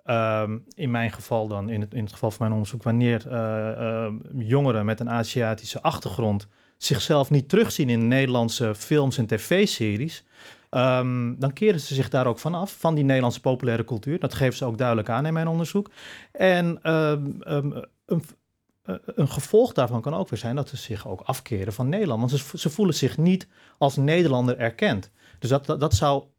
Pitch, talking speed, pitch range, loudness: 130 Hz, 190 wpm, 115-150 Hz, -24 LUFS